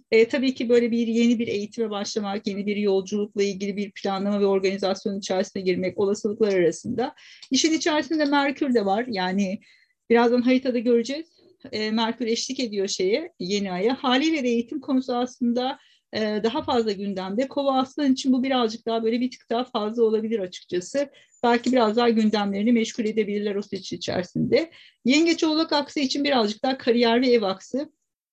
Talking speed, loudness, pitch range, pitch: 165 wpm, -24 LUFS, 205-260 Hz, 235 Hz